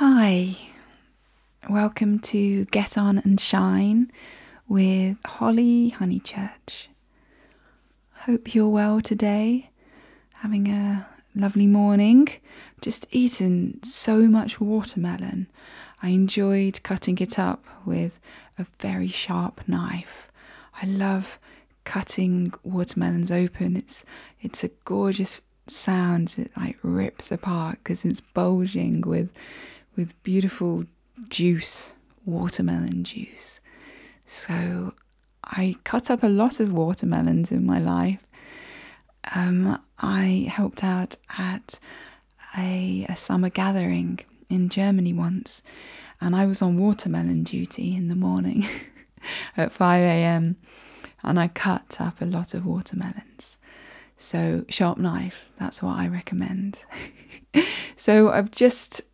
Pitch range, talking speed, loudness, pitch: 175-215 Hz, 110 wpm, -24 LUFS, 195 Hz